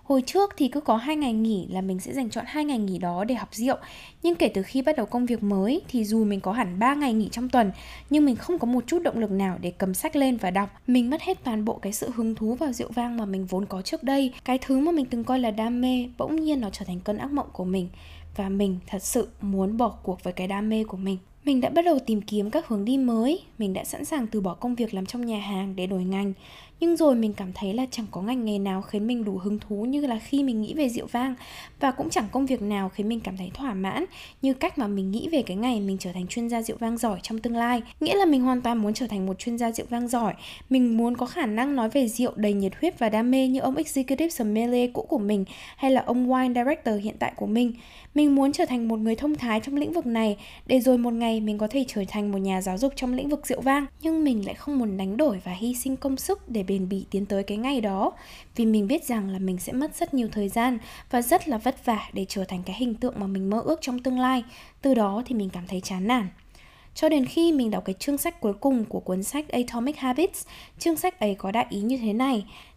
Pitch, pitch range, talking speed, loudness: 235 Hz, 205-270 Hz, 280 wpm, -26 LUFS